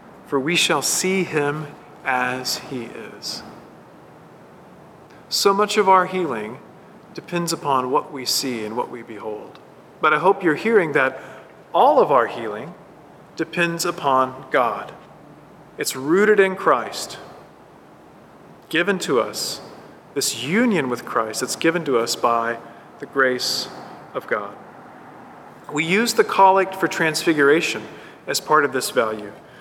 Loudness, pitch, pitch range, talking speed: -20 LUFS, 165 Hz, 130-190 Hz, 135 wpm